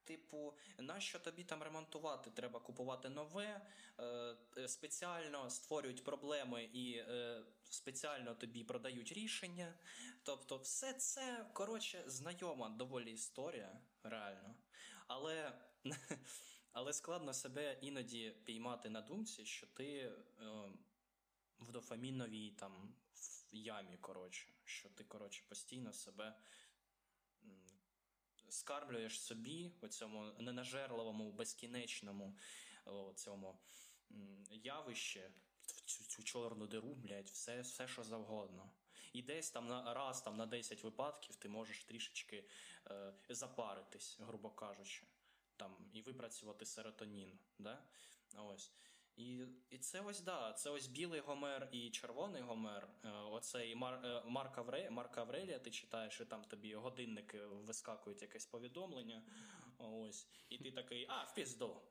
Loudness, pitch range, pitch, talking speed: -50 LUFS, 110-145 Hz, 125 Hz, 115 wpm